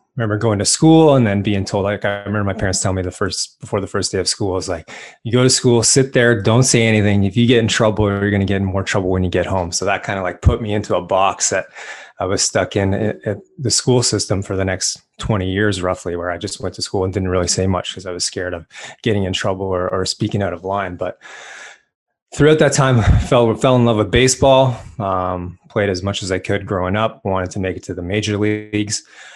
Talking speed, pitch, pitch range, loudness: 265 wpm, 100 Hz, 95-115 Hz, -17 LUFS